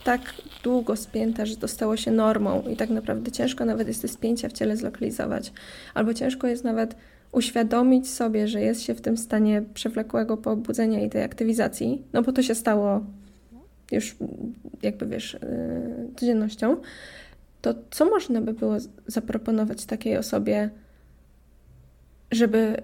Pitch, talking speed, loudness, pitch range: 225 Hz, 145 wpm, -26 LUFS, 200-245 Hz